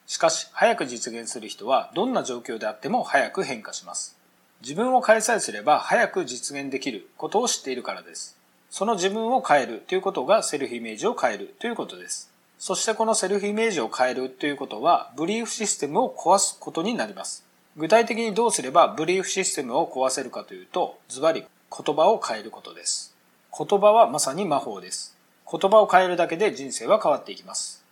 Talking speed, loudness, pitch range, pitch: 425 characters per minute, -24 LUFS, 135-220 Hz, 180 Hz